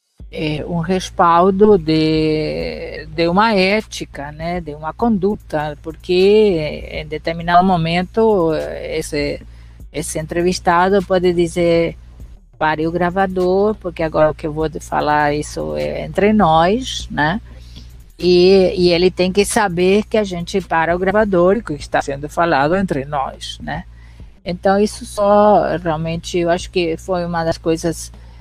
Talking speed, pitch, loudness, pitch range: 140 wpm, 170 Hz, -16 LUFS, 155-190 Hz